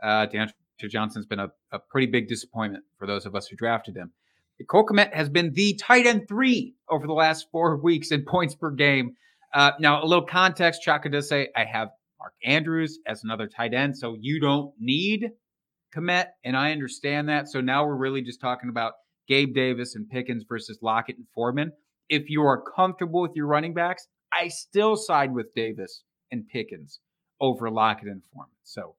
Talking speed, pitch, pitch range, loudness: 195 wpm, 145 Hz, 120-170 Hz, -24 LUFS